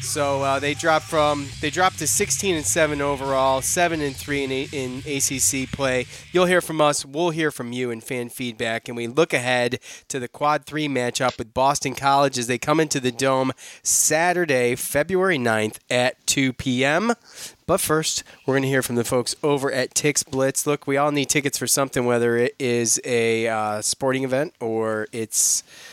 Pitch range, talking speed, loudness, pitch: 125-150 Hz, 195 wpm, -21 LUFS, 135 Hz